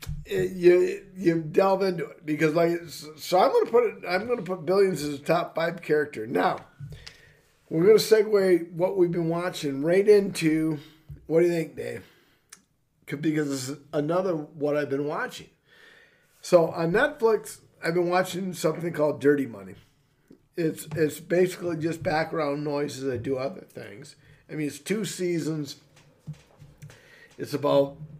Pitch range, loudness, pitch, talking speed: 145-180 Hz, -25 LUFS, 160 Hz, 150 wpm